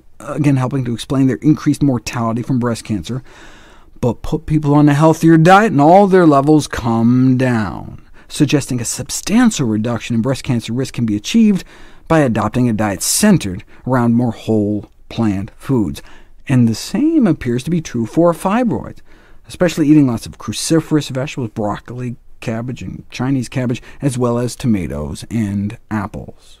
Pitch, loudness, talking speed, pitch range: 125 Hz, -15 LUFS, 160 wpm, 110-150 Hz